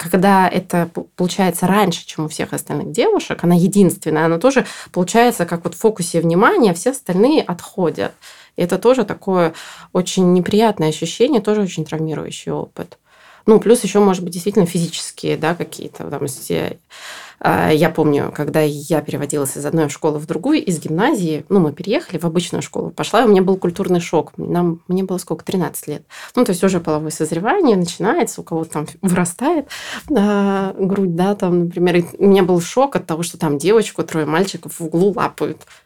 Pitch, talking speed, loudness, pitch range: 180 Hz, 175 wpm, -17 LUFS, 160-200 Hz